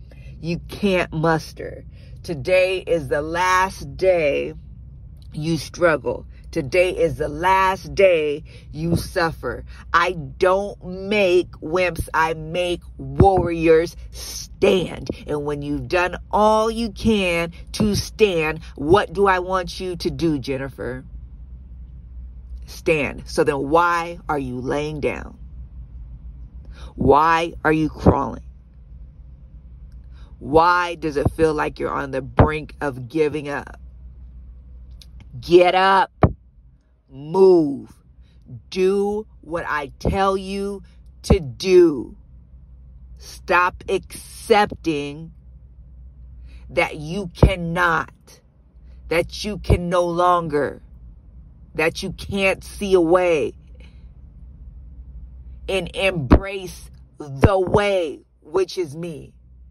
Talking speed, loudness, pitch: 100 wpm, -20 LUFS, 150 Hz